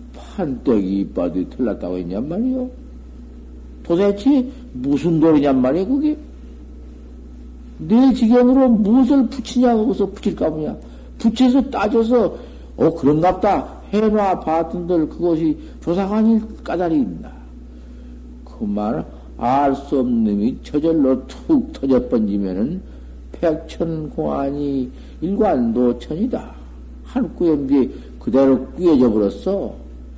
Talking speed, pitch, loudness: 235 characters per minute, 150 Hz, -18 LUFS